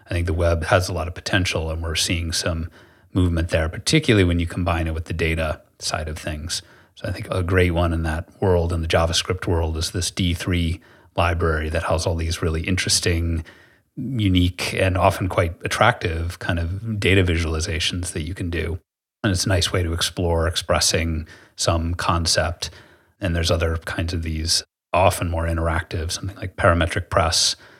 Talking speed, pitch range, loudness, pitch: 185 wpm, 85-95 Hz, -22 LUFS, 85 Hz